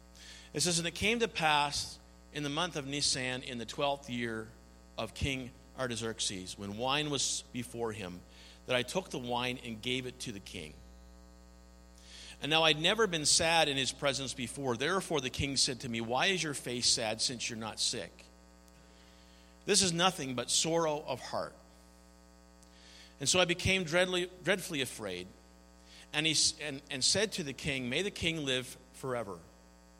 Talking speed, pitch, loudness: 175 wpm, 125 Hz, -32 LUFS